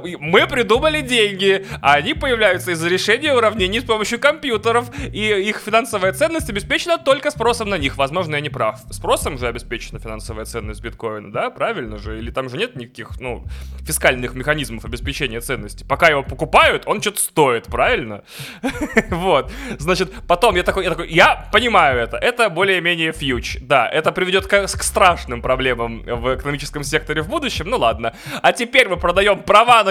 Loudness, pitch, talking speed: -17 LUFS, 160 Hz, 165 wpm